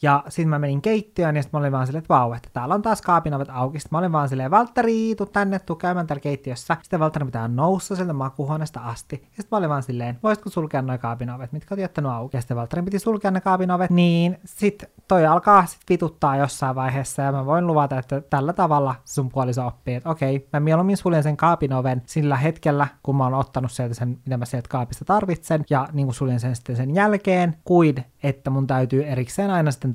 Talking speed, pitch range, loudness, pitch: 220 wpm, 130-175 Hz, -22 LUFS, 145 Hz